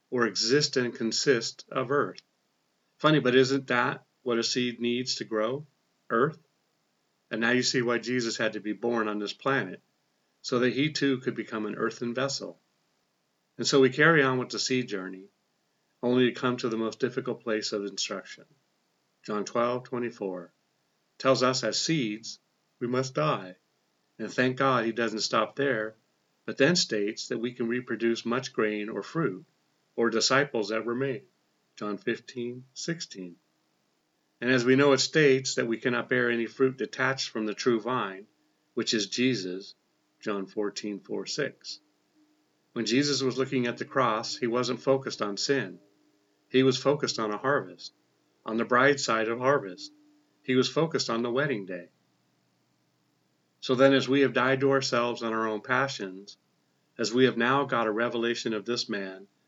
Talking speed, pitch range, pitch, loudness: 170 wpm, 110-130 Hz, 120 Hz, -27 LUFS